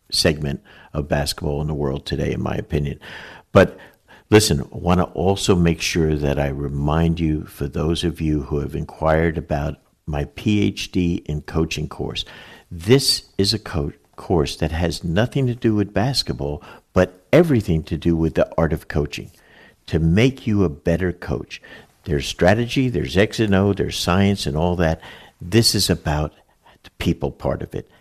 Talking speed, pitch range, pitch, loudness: 175 wpm, 75-100 Hz, 85 Hz, -20 LUFS